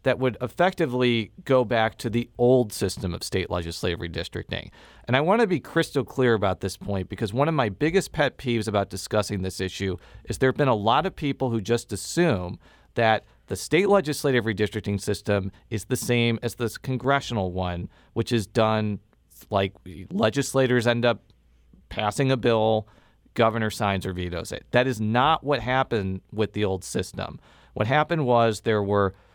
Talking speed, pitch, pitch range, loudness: 180 wpm, 110 Hz, 100-130 Hz, -25 LUFS